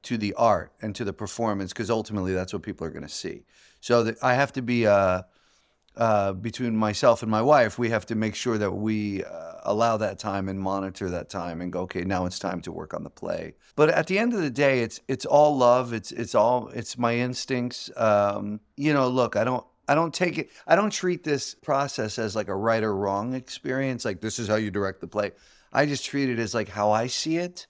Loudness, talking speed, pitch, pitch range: -25 LUFS, 245 wpm, 115 Hz, 100-130 Hz